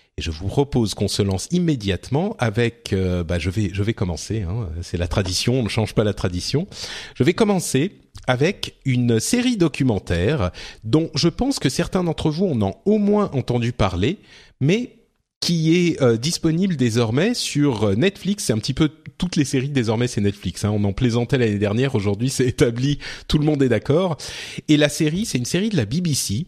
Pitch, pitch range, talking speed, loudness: 130 Hz, 105-160 Hz, 195 wpm, -21 LUFS